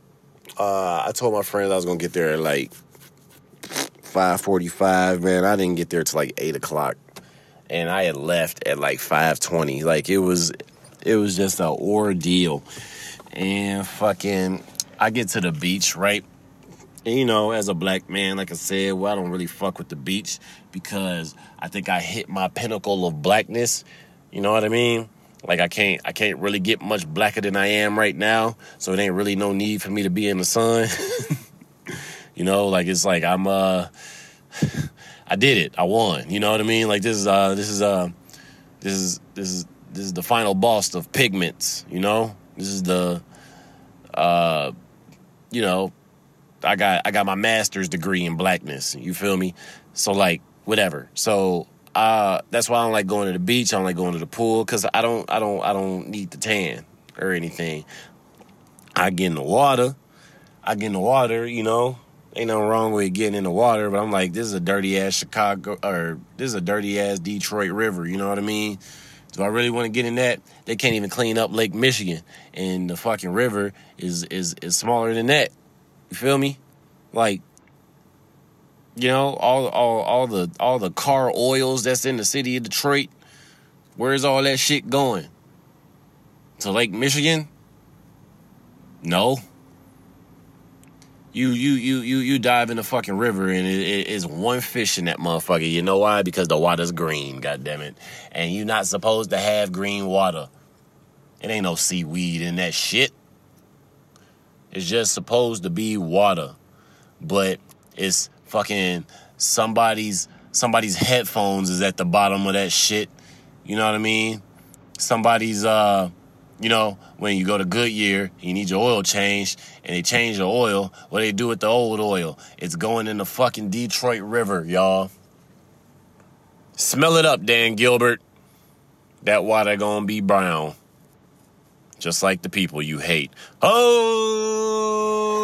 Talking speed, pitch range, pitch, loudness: 180 wpm, 95-115 Hz, 100 Hz, -21 LUFS